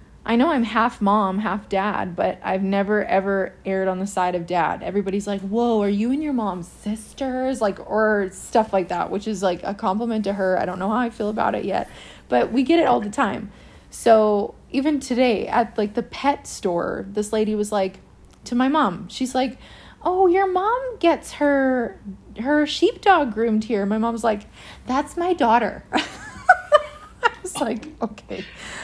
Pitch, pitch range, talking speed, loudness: 225 Hz, 200-270 Hz, 185 wpm, -22 LUFS